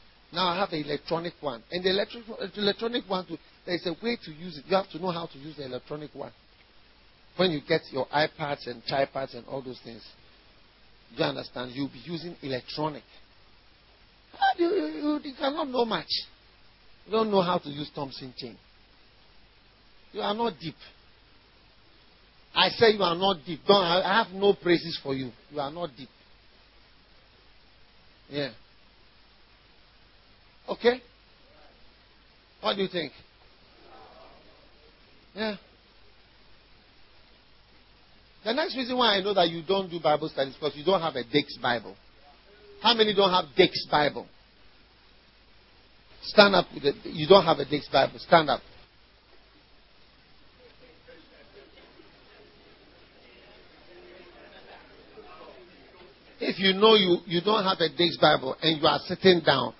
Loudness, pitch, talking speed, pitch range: -26 LUFS, 145 Hz, 140 wpm, 110-185 Hz